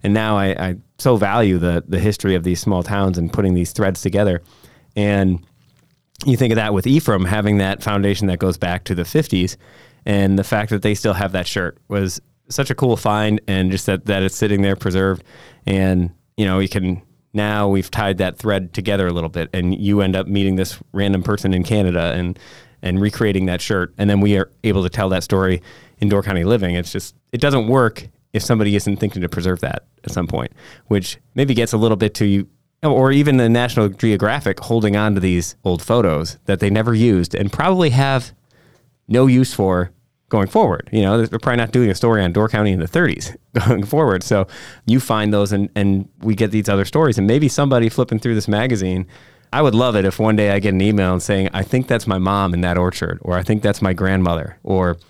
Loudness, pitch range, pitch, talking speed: -18 LUFS, 95-115 Hz, 100 Hz, 225 wpm